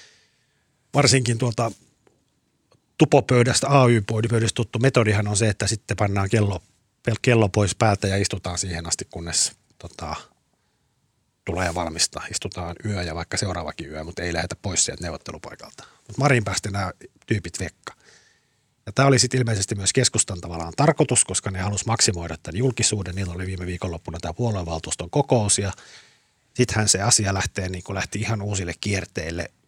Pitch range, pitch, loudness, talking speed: 95-120 Hz, 105 Hz, -22 LUFS, 150 wpm